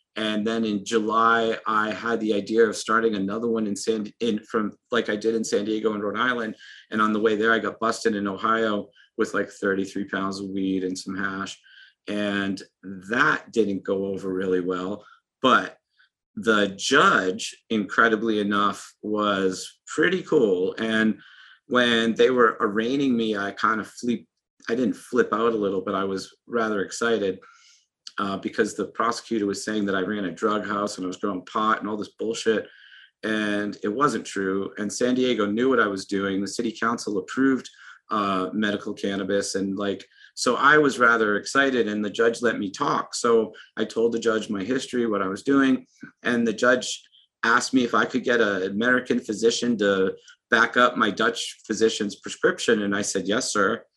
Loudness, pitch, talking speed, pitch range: -24 LUFS, 105 Hz, 185 wpm, 100-115 Hz